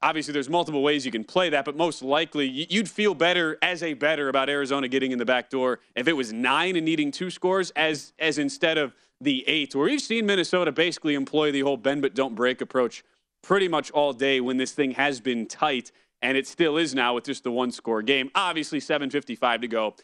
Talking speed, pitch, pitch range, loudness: 230 wpm, 145 Hz, 130-165 Hz, -25 LUFS